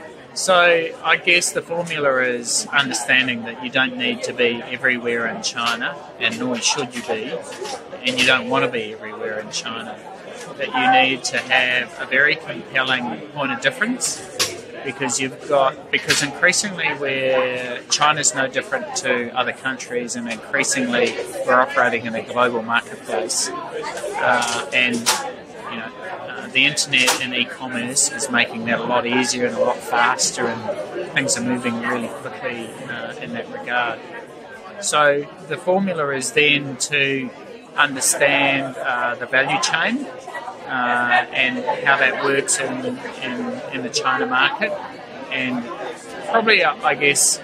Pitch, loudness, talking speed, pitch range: 130 Hz, -19 LUFS, 150 wpm, 125-150 Hz